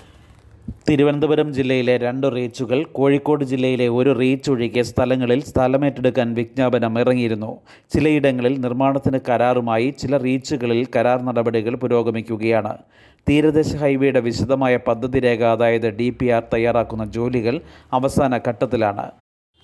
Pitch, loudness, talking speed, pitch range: 125 Hz, -19 LUFS, 95 wpm, 115-135 Hz